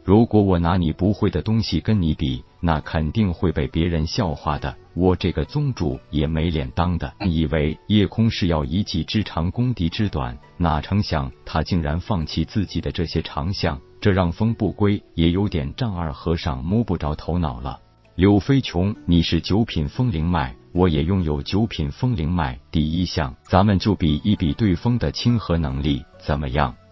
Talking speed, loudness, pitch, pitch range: 265 characters per minute, -22 LUFS, 85 Hz, 80-100 Hz